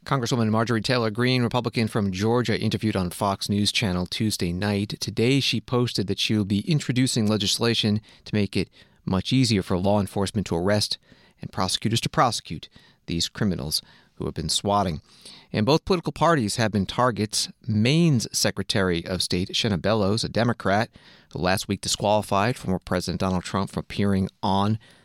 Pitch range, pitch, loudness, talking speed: 100-115 Hz, 105 Hz, -24 LUFS, 165 wpm